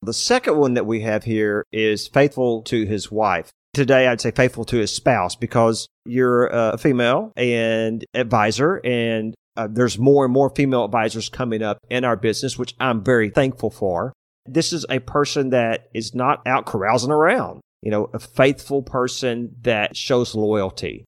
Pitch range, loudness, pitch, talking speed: 110-130 Hz, -20 LUFS, 120 Hz, 175 wpm